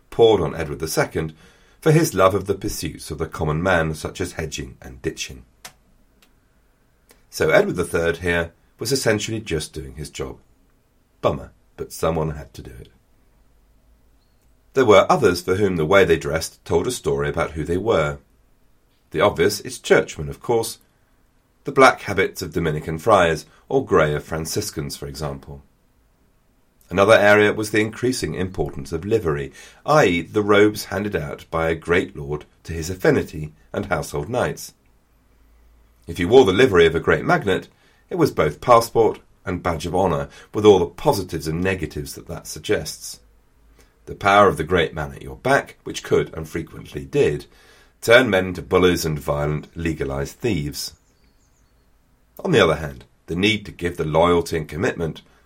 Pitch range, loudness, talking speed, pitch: 75-100 Hz, -20 LUFS, 165 wpm, 80 Hz